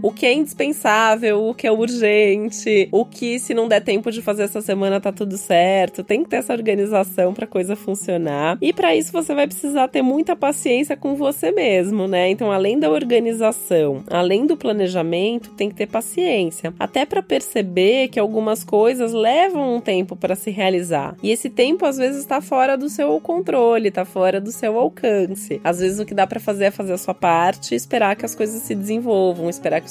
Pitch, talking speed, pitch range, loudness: 210 Hz, 205 wpm, 190-245 Hz, -19 LUFS